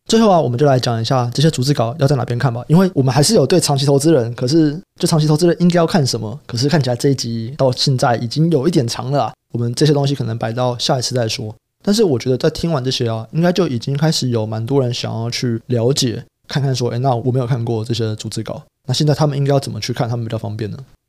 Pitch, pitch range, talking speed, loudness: 130 Hz, 120-150 Hz, 405 characters per minute, -16 LUFS